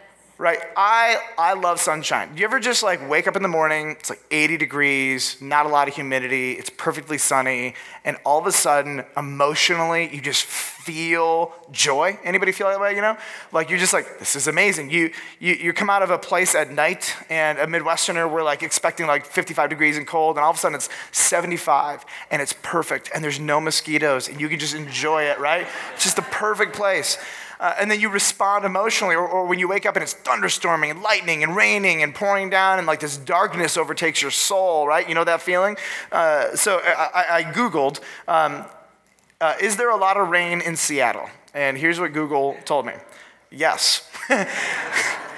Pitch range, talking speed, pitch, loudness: 150-190 Hz, 200 wpm, 165 Hz, -20 LUFS